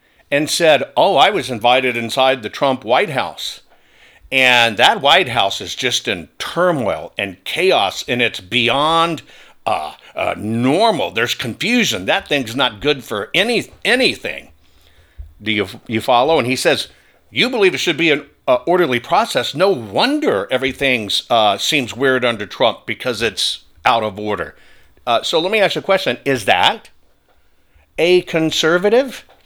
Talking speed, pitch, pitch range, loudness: 155 wpm, 130 Hz, 110-165 Hz, -16 LUFS